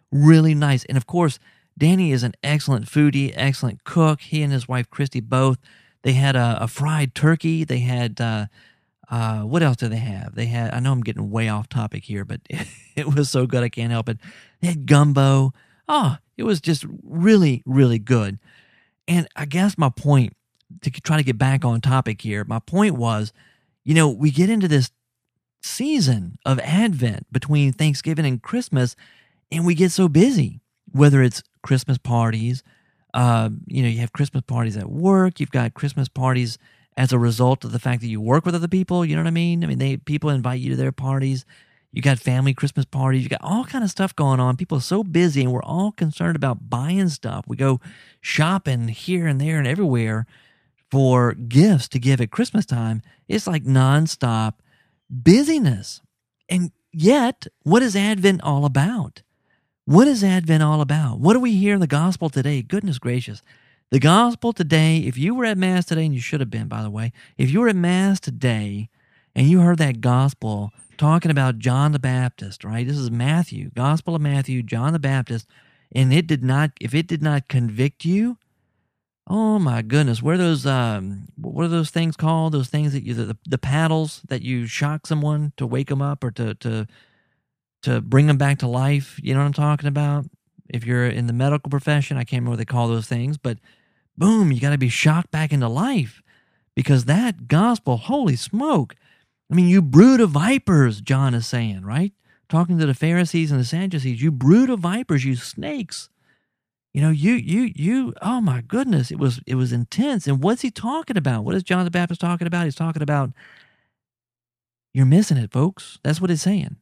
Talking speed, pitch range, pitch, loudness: 200 wpm, 125-165 Hz, 140 Hz, -20 LUFS